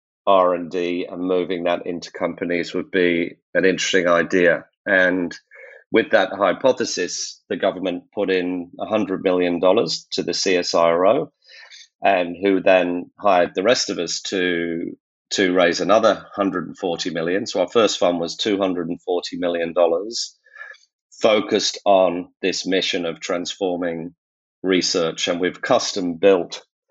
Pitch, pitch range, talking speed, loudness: 90 Hz, 85-95 Hz, 130 wpm, -20 LUFS